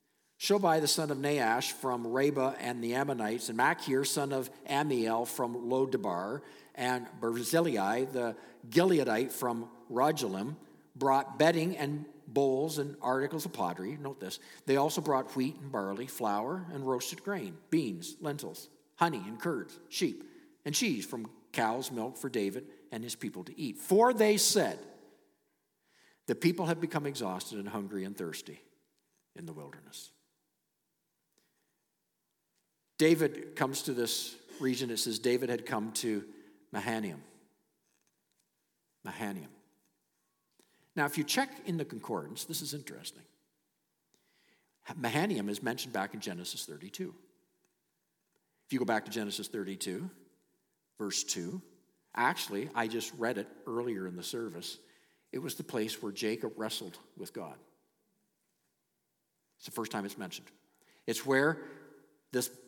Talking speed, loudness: 135 wpm, -33 LUFS